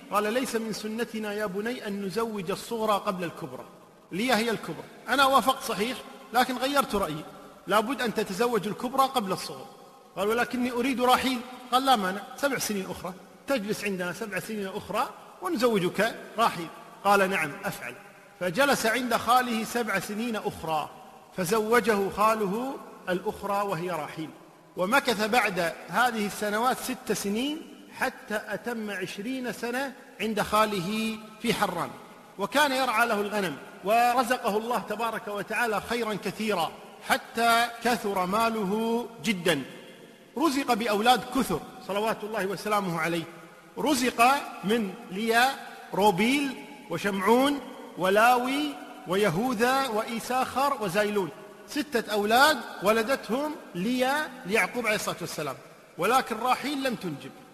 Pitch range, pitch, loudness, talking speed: 200-245 Hz, 220 Hz, -27 LUFS, 120 wpm